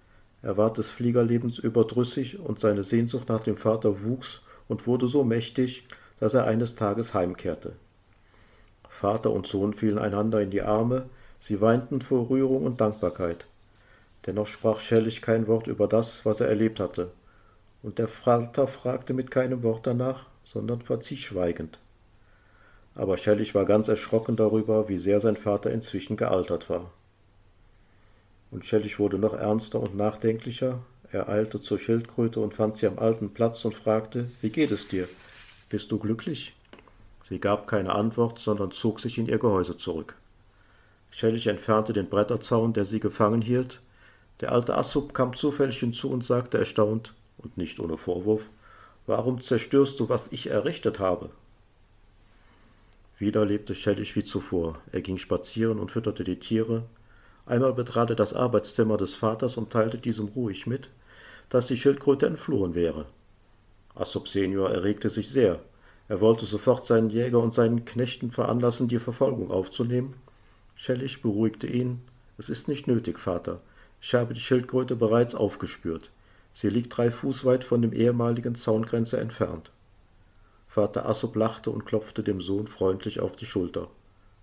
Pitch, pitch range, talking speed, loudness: 110 Hz, 100-120 Hz, 155 wpm, -27 LUFS